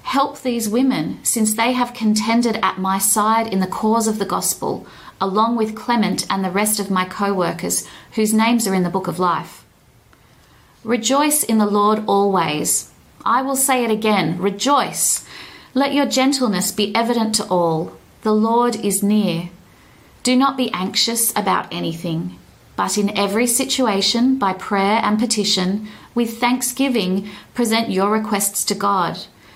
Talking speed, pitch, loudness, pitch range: 155 wpm, 215 Hz, -18 LUFS, 195-240 Hz